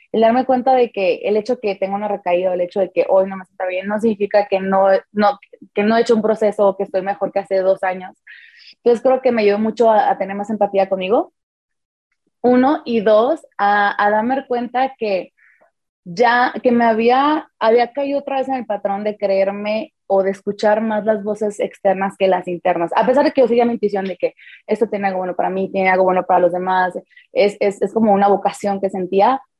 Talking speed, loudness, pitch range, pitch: 230 wpm, -17 LUFS, 195-240 Hz, 205 Hz